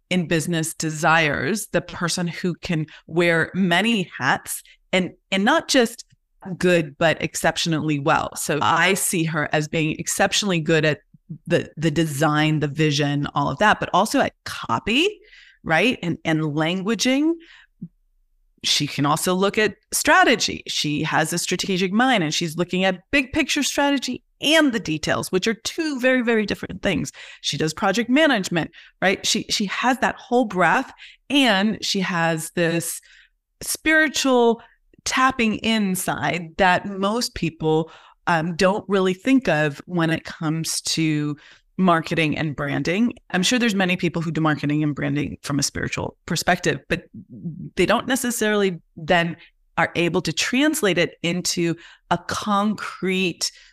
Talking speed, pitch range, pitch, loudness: 145 wpm, 160-215 Hz, 175 Hz, -21 LUFS